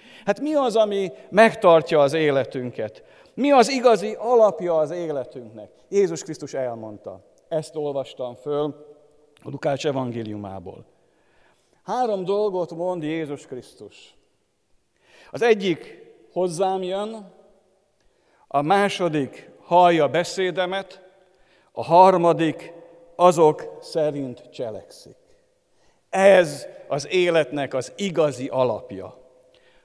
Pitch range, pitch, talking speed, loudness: 145-200 Hz, 170 Hz, 90 wpm, -21 LUFS